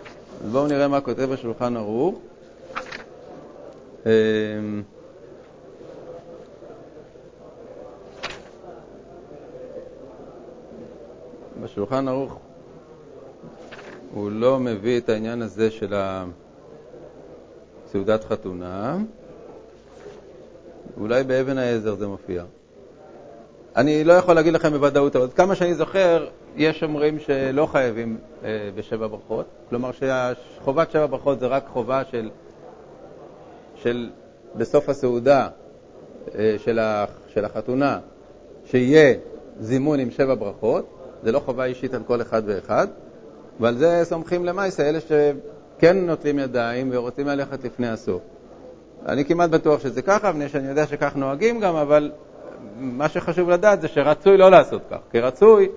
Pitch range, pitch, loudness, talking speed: 115-160 Hz, 135 Hz, -21 LUFS, 110 wpm